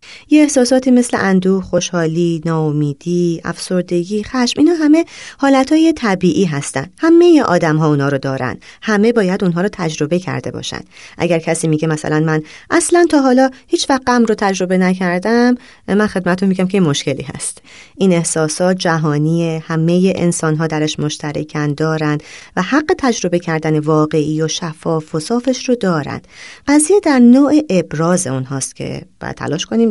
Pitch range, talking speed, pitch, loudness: 160-245 Hz, 150 wpm, 180 Hz, -15 LUFS